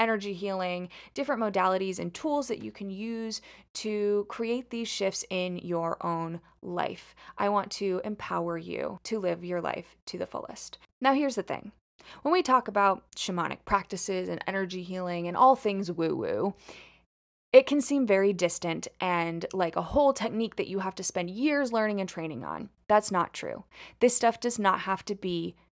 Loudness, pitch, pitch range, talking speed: -29 LUFS, 195 Hz, 180-230 Hz, 180 wpm